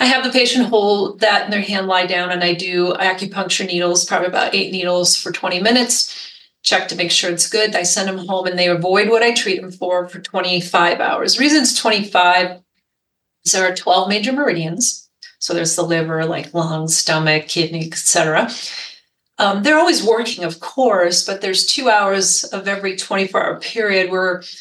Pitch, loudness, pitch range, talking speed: 185 Hz, -16 LUFS, 175-210 Hz, 190 wpm